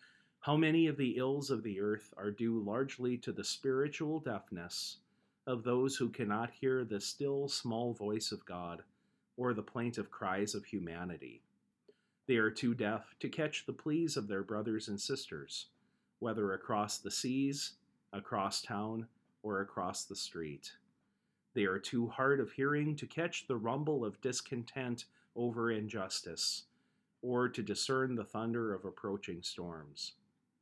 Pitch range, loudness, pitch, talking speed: 105-135 Hz, -38 LUFS, 120 Hz, 150 wpm